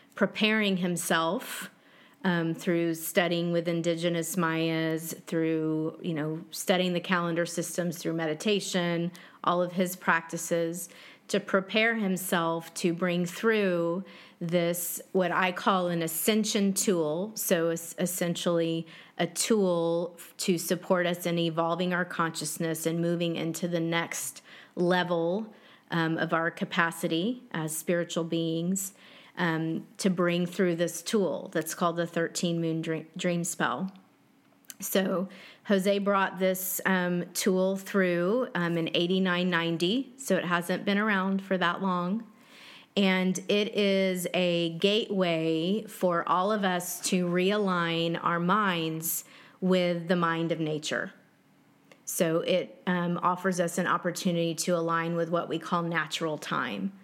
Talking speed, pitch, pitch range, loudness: 130 wpm, 175 Hz, 165-190 Hz, -28 LUFS